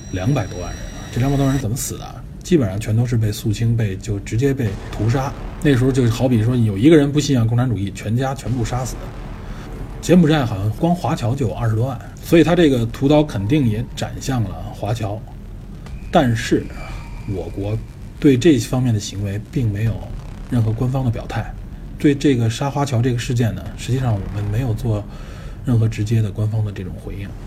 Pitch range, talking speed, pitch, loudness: 105-130 Hz, 300 characters per minute, 115 Hz, -19 LUFS